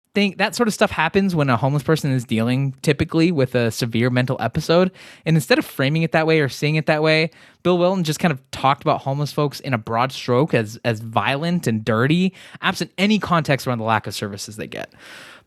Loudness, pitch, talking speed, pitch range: -20 LUFS, 145 Hz, 220 wpm, 125-165 Hz